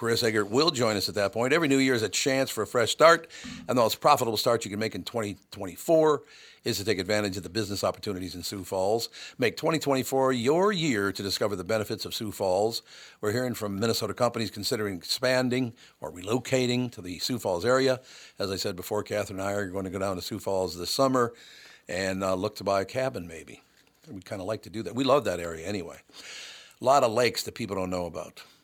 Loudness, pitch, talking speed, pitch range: -27 LUFS, 105 Hz, 230 wpm, 95-125 Hz